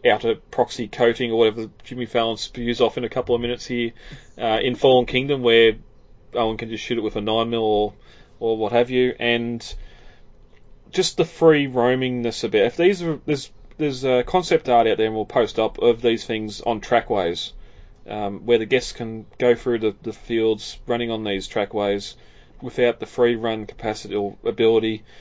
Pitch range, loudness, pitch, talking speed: 110-125 Hz, -21 LUFS, 115 Hz, 190 wpm